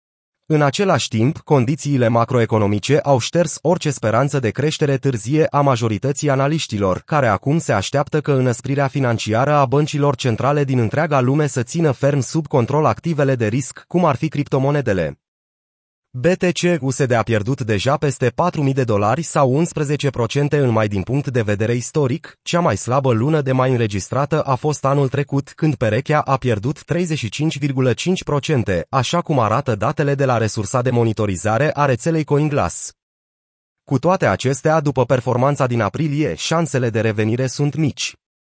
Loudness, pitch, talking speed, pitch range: -18 LUFS, 135 Hz, 150 wpm, 120-150 Hz